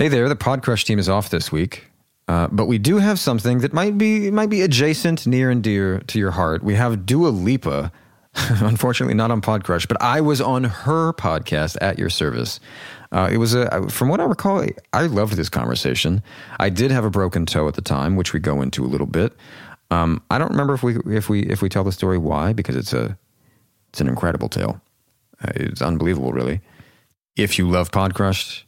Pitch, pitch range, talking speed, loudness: 105 Hz, 90-125 Hz, 210 wpm, -20 LUFS